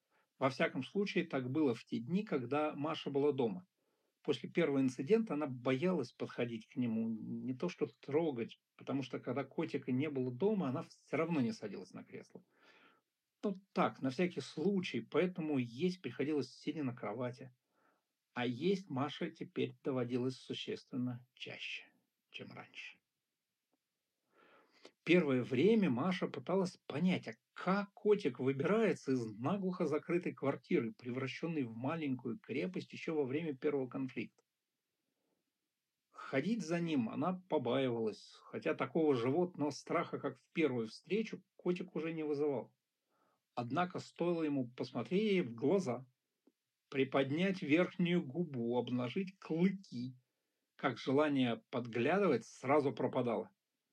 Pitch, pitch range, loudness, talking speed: 145 Hz, 130-180 Hz, -37 LUFS, 125 wpm